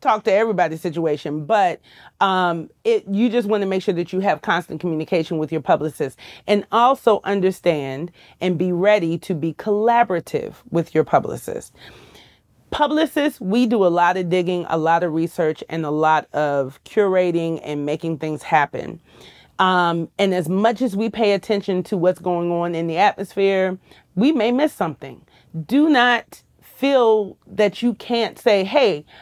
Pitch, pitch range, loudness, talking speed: 180 Hz, 165-210 Hz, -20 LUFS, 165 wpm